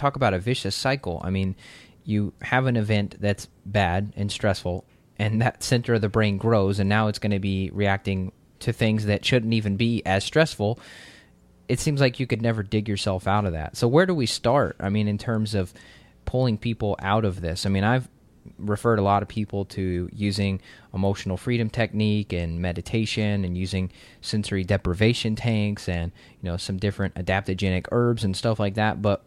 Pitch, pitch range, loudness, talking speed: 105 Hz, 95-115 Hz, -25 LUFS, 195 wpm